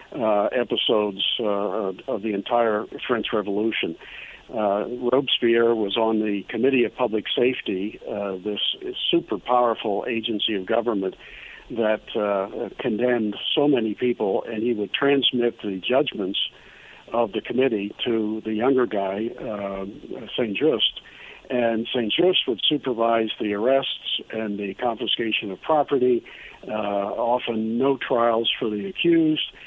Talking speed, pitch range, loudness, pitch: 130 wpm, 105-125 Hz, -23 LUFS, 115 Hz